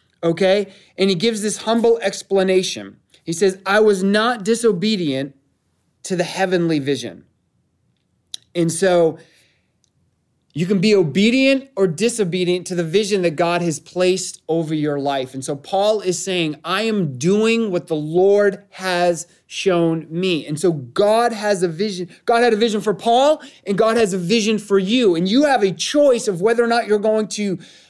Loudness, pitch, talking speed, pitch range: -18 LUFS, 190 Hz, 170 wpm, 170-215 Hz